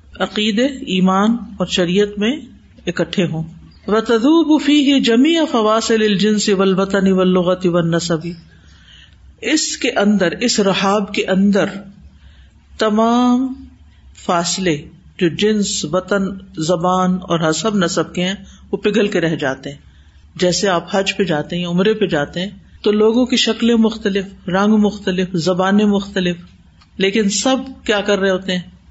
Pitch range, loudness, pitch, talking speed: 175-215 Hz, -16 LUFS, 195 Hz, 135 wpm